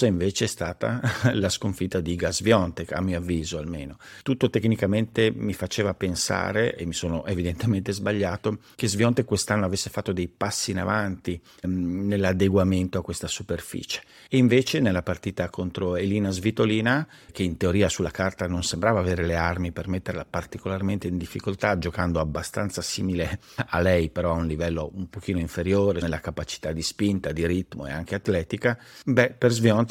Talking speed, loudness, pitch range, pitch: 160 wpm, -25 LUFS, 85-105 Hz, 95 Hz